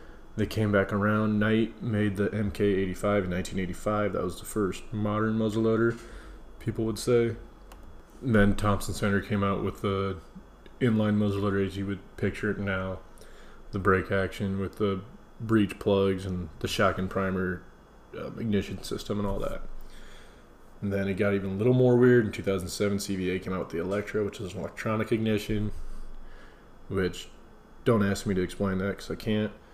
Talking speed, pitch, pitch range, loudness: 170 wpm, 100 Hz, 95-110 Hz, -28 LUFS